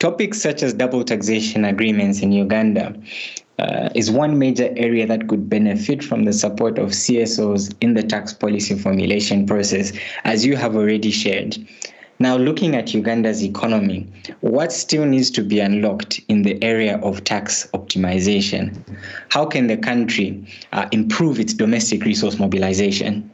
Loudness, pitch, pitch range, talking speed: -18 LUFS, 110 Hz, 105-130 Hz, 150 wpm